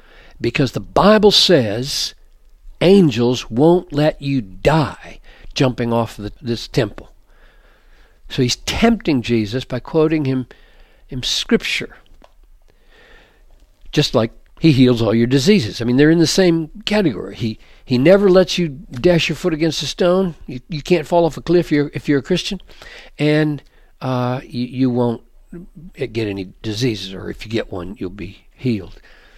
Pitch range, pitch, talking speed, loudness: 115-170 Hz, 135 Hz, 155 wpm, -17 LUFS